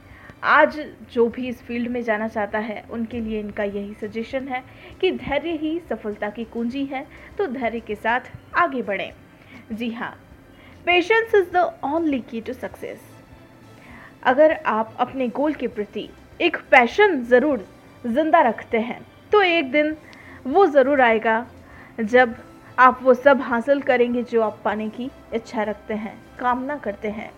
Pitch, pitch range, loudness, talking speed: 245 Hz, 225-295 Hz, -21 LUFS, 155 wpm